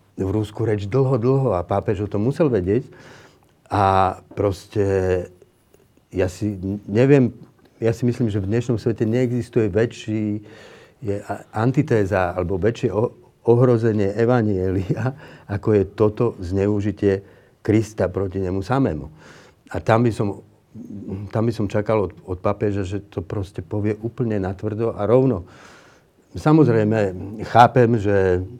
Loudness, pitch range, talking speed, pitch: -21 LUFS, 100-115 Hz, 130 wpm, 105 Hz